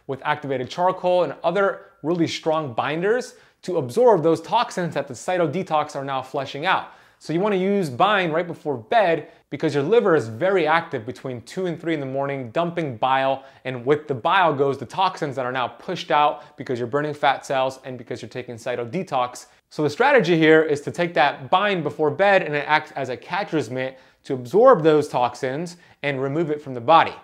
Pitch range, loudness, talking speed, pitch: 135-170 Hz, -21 LUFS, 205 wpm, 150 Hz